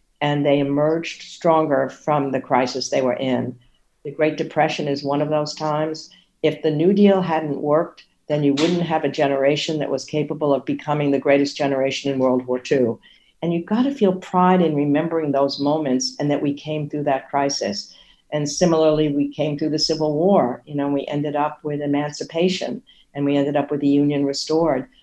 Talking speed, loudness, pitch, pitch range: 195 wpm, -20 LUFS, 150 Hz, 140-155 Hz